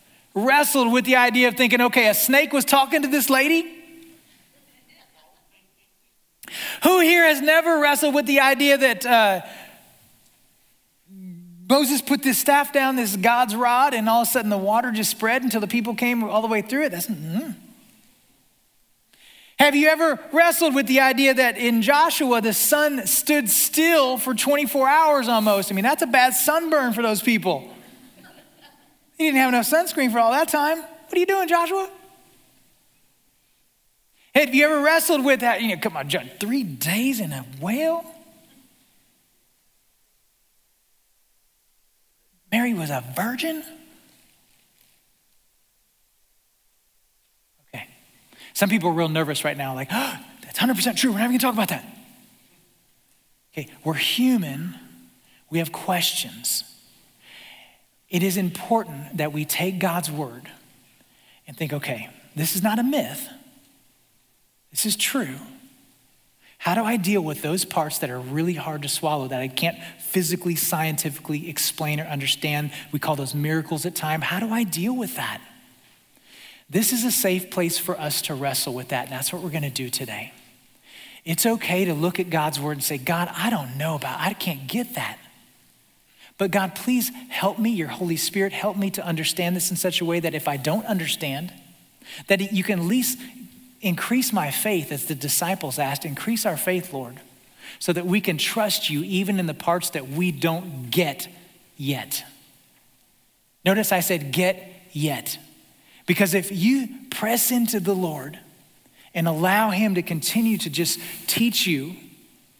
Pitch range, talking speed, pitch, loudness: 165-255 Hz, 160 wpm, 200 Hz, -21 LUFS